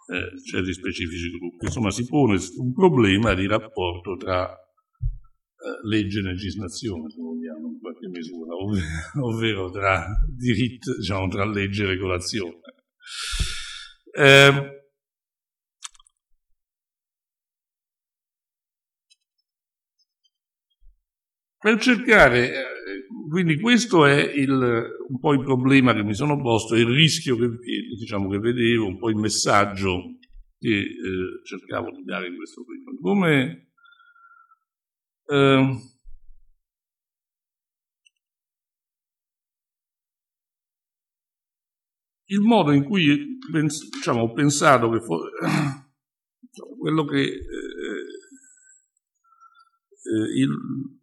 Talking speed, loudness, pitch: 95 wpm, -21 LUFS, 130 Hz